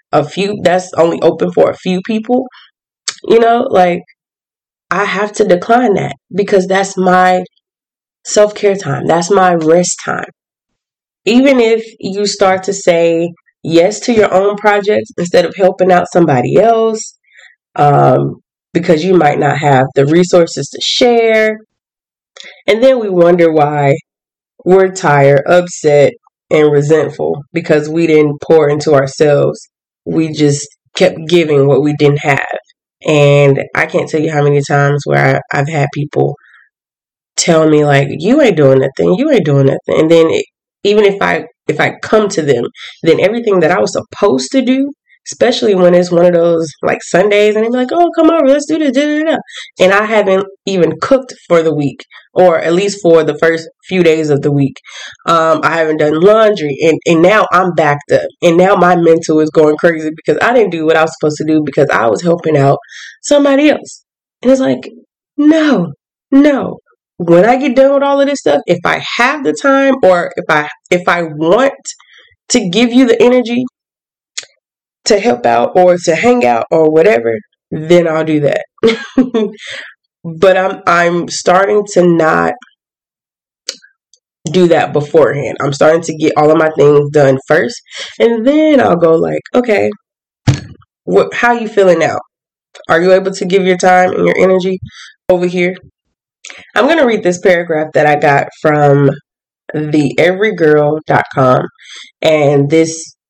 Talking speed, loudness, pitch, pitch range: 170 wpm, -11 LUFS, 175 Hz, 155-210 Hz